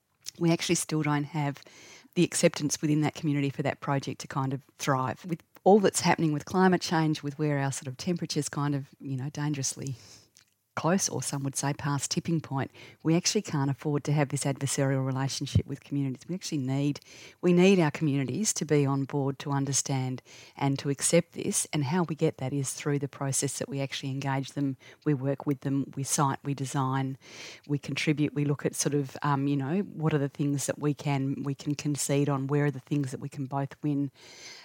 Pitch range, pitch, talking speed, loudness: 135-155 Hz, 145 Hz, 210 wpm, -29 LUFS